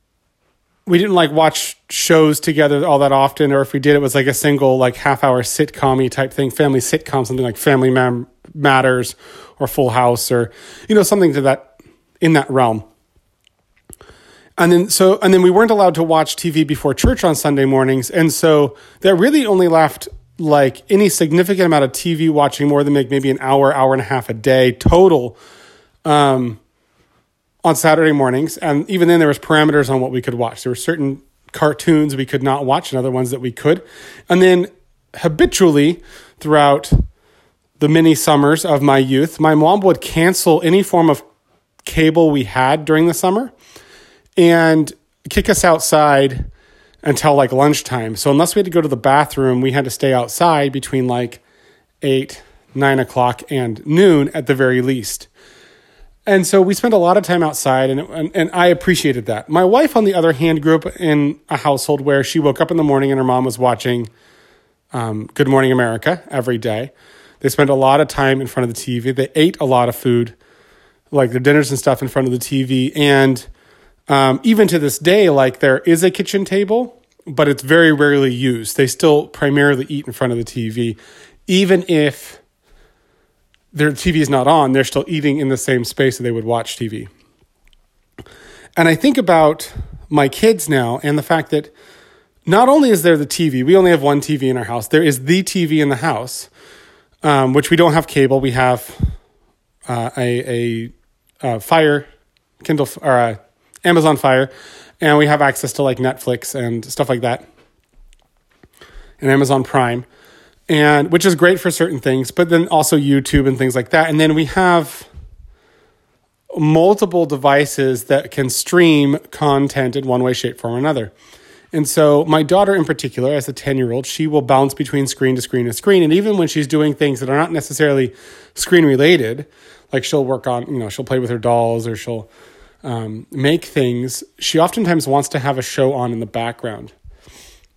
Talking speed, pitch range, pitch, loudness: 190 wpm, 130-160 Hz, 145 Hz, -14 LUFS